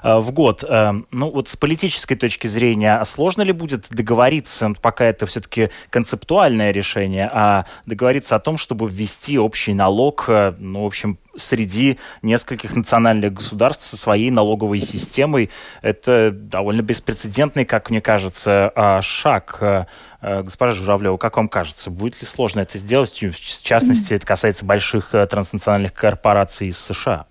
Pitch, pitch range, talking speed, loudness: 110 Hz, 100-120 Hz, 140 wpm, -18 LUFS